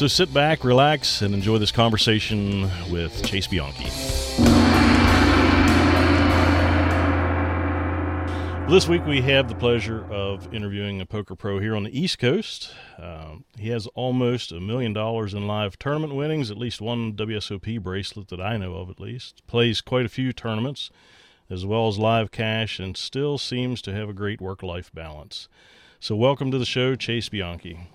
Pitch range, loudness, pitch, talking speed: 95-120 Hz, -22 LUFS, 105 Hz, 165 wpm